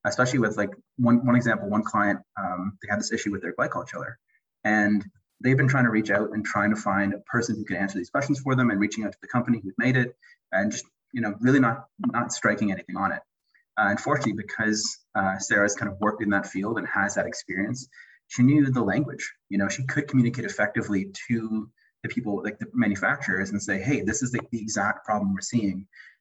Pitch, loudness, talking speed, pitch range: 110 Hz, -26 LUFS, 225 wpm, 100-125 Hz